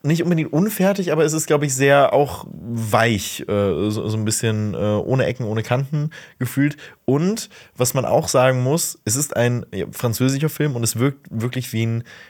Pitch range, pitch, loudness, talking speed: 115-150 Hz, 130 Hz, -20 LUFS, 175 wpm